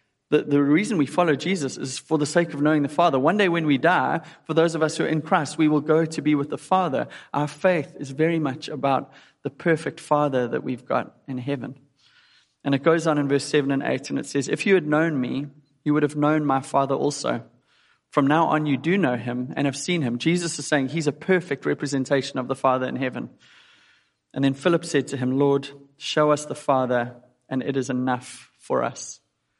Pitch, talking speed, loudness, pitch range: 145 Hz, 230 wpm, -23 LUFS, 135-160 Hz